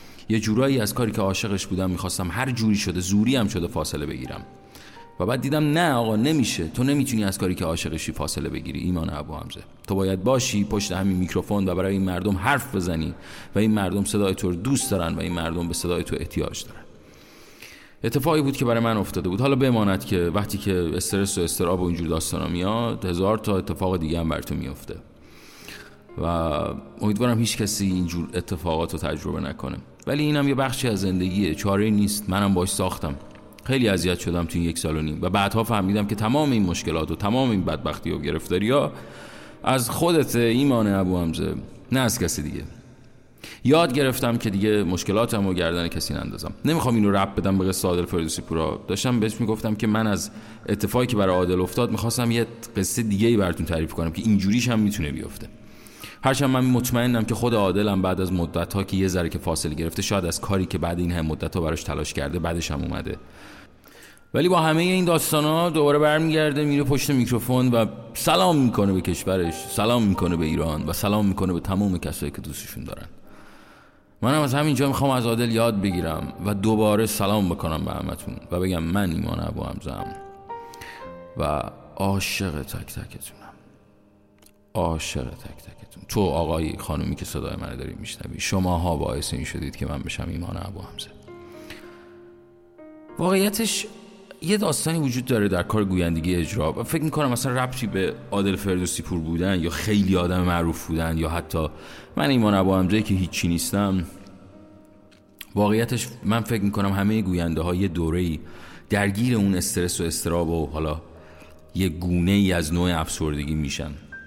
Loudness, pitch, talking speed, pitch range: -23 LUFS, 100 Hz, 180 wpm, 85-115 Hz